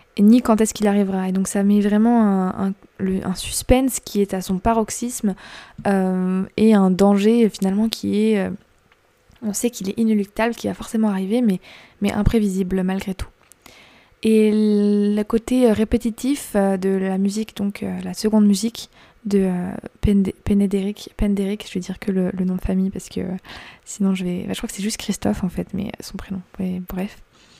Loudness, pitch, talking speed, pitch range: -20 LUFS, 205 Hz, 185 wpm, 190-220 Hz